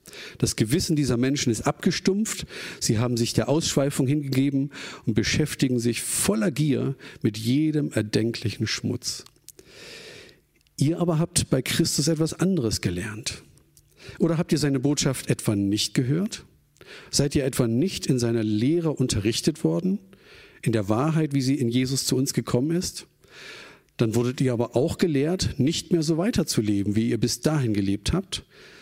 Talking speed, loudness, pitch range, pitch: 150 wpm, -24 LUFS, 120-160 Hz, 135 Hz